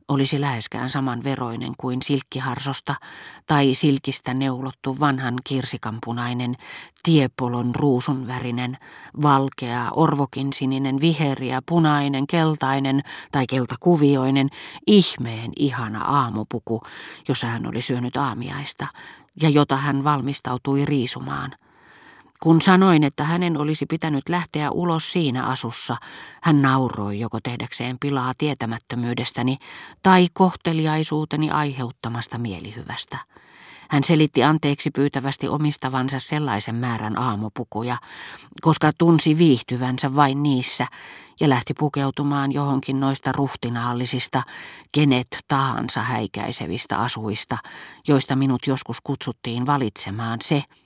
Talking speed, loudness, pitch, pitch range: 100 wpm, -22 LUFS, 135 Hz, 125-145 Hz